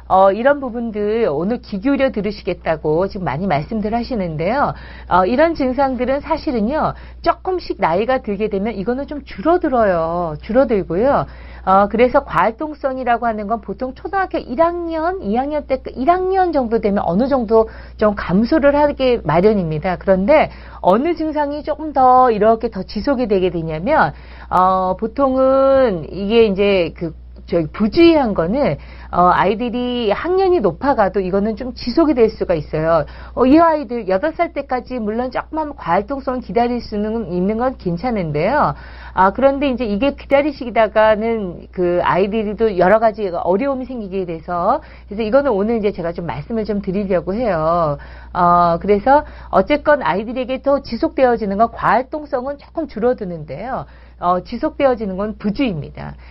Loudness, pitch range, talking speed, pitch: -17 LUFS, 190-275 Hz, 330 characters per minute, 230 Hz